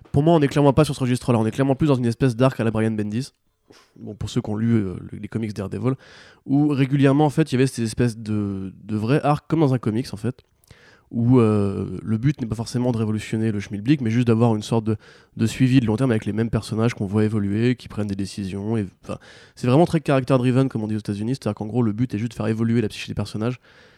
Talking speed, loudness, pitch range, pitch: 280 wpm, -22 LUFS, 105-130 Hz, 115 Hz